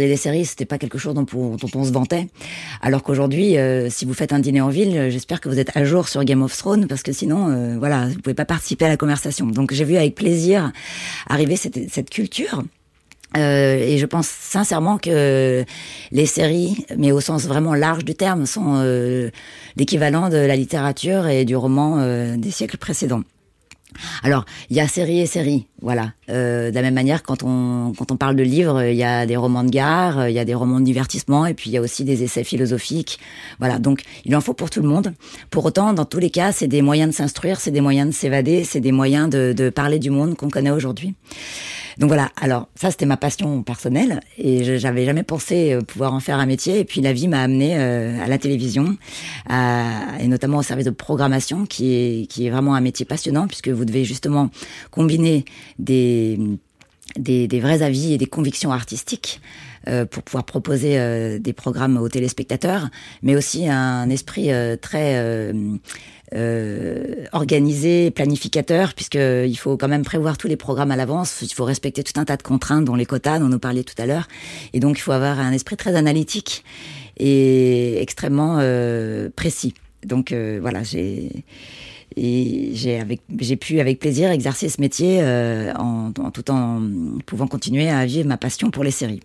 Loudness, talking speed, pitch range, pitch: -19 LUFS, 205 wpm, 125-155 Hz, 135 Hz